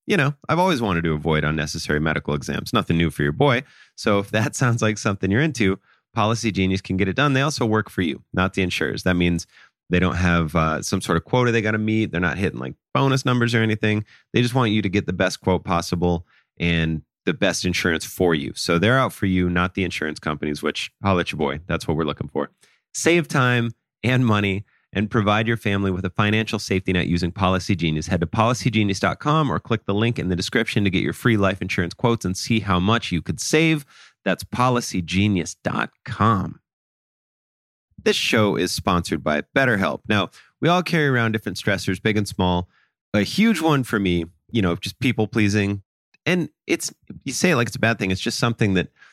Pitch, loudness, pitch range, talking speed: 100 Hz, -21 LUFS, 90-115 Hz, 215 wpm